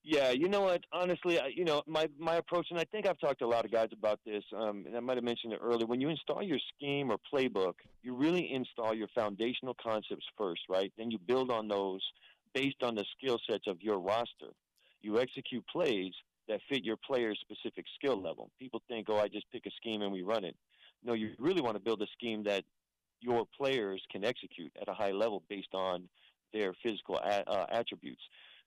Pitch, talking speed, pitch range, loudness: 115 Hz, 220 wpm, 105-135 Hz, -36 LUFS